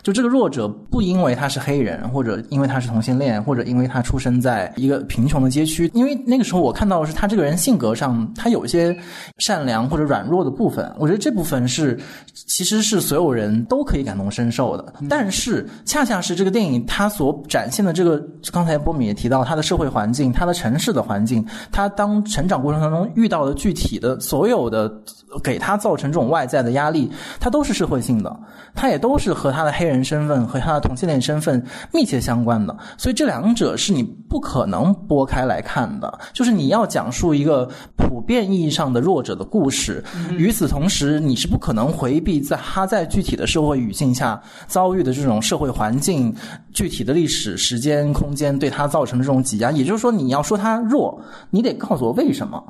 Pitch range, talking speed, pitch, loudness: 125-190 Hz, 325 characters per minute, 150 Hz, -19 LUFS